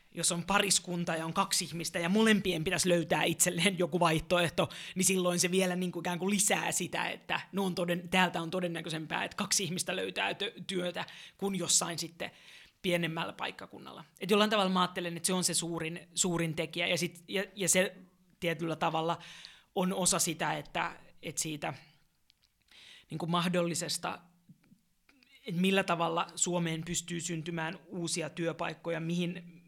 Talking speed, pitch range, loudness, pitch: 160 wpm, 170-185 Hz, -31 LUFS, 175 Hz